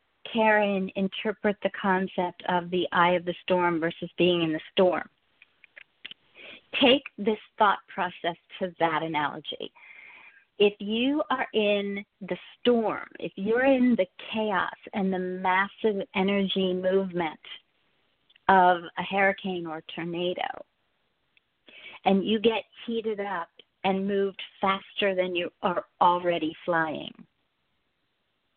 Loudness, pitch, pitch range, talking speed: -27 LUFS, 190 Hz, 175-205 Hz, 120 wpm